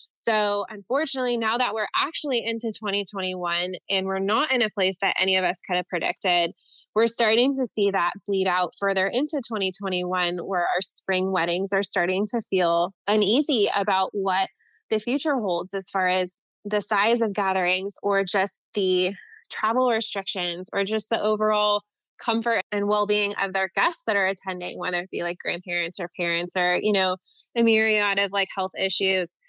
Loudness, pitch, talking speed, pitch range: -24 LUFS, 195 Hz, 175 wpm, 185-220 Hz